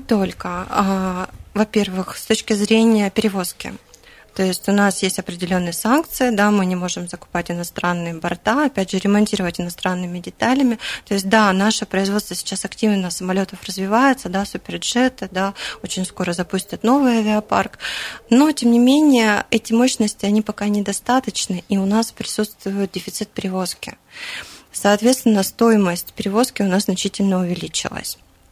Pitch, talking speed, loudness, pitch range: 200 Hz, 135 wpm, -19 LUFS, 185-220 Hz